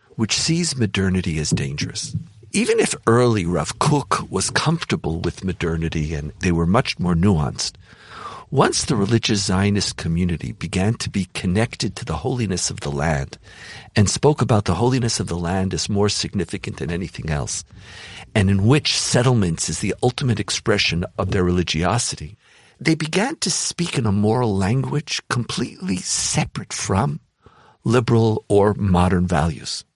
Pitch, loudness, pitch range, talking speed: 105 Hz, -20 LUFS, 90-125 Hz, 150 wpm